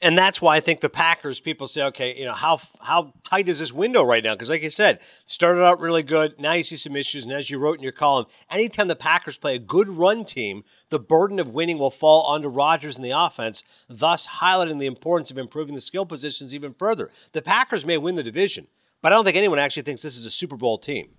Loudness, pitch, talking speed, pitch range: -21 LUFS, 155 Hz, 250 wpm, 140-175 Hz